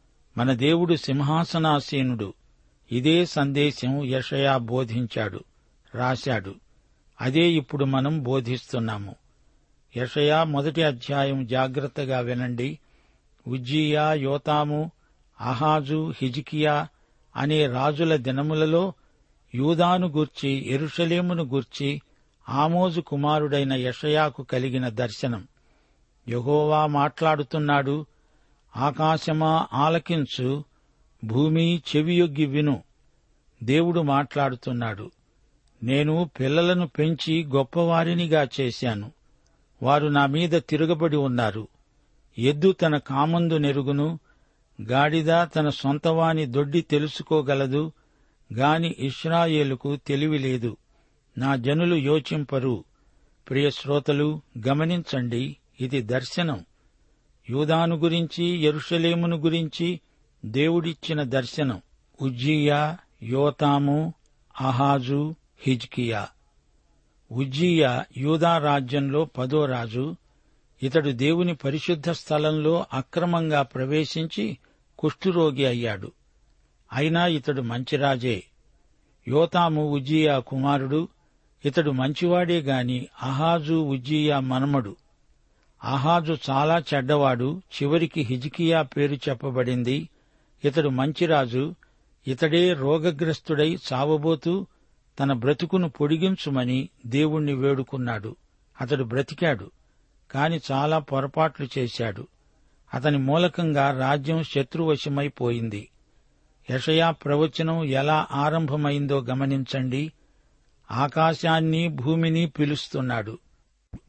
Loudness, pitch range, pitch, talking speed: -24 LUFS, 130-160 Hz, 145 Hz, 75 wpm